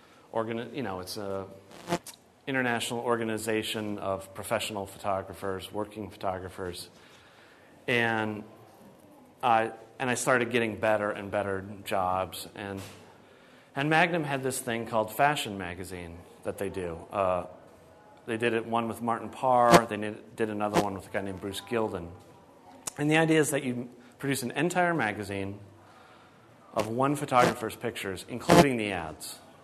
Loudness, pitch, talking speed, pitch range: -29 LUFS, 110 Hz, 140 wpm, 95-120 Hz